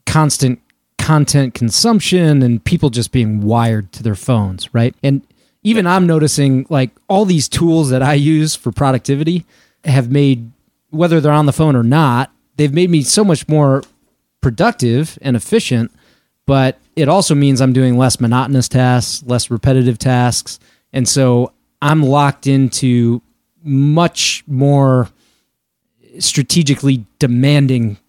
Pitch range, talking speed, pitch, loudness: 125-155 Hz, 135 wpm, 135 Hz, -13 LUFS